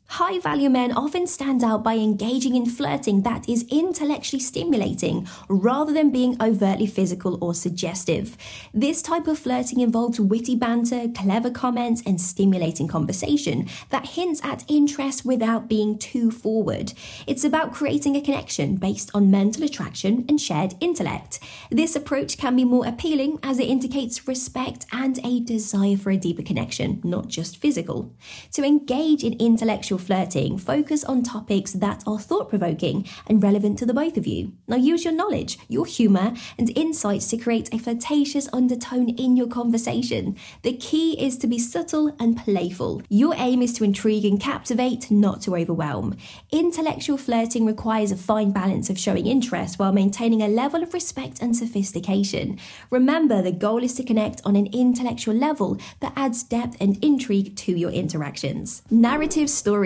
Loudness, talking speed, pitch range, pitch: -22 LUFS, 160 wpm, 205-275 Hz, 235 Hz